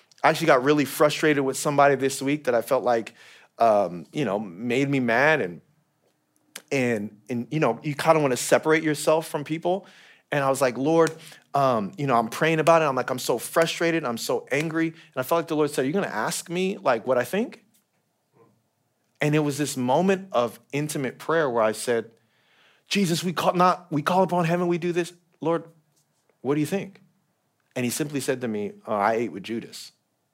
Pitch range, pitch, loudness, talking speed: 130-170 Hz, 150 Hz, -24 LUFS, 210 wpm